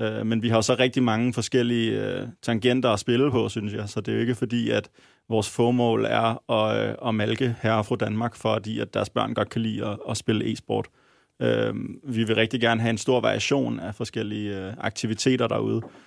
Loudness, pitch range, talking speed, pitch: -25 LUFS, 110-120 Hz, 200 wpm, 115 Hz